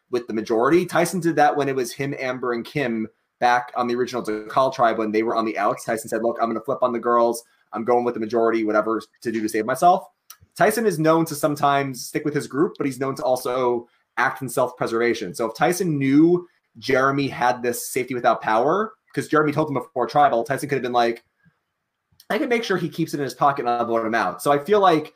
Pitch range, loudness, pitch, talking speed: 115-150 Hz, -22 LUFS, 125 Hz, 250 wpm